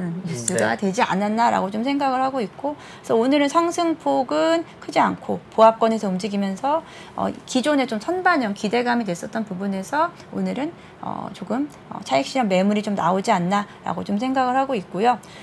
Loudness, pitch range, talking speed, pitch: -22 LUFS, 200-275 Hz, 355 characters per minute, 235 Hz